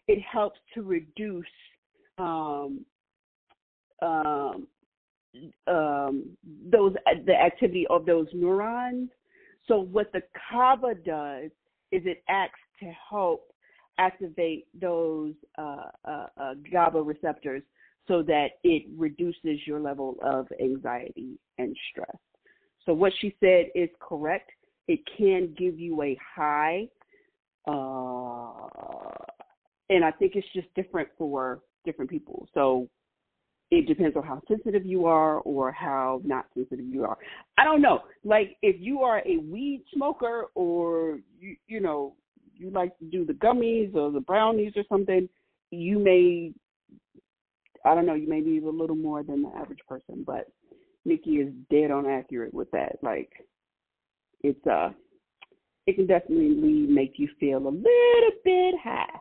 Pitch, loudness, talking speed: 185 Hz, -26 LUFS, 140 wpm